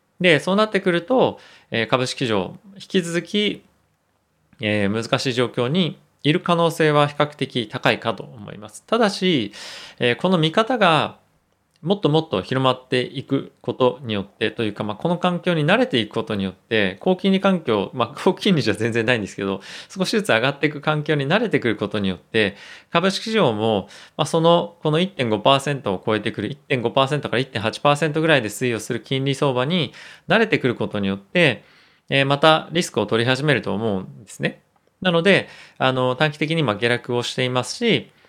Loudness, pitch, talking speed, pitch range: -20 LUFS, 140 Hz, 335 characters per minute, 115-170 Hz